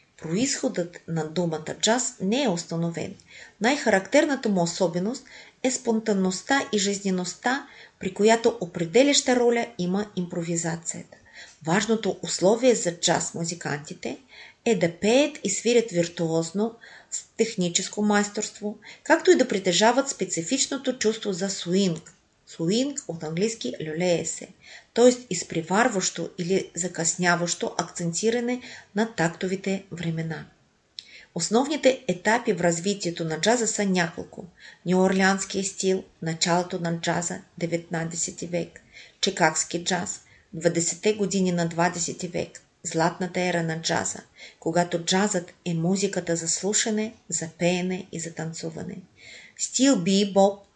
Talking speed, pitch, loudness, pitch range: 110 wpm, 185 Hz, -25 LUFS, 170-220 Hz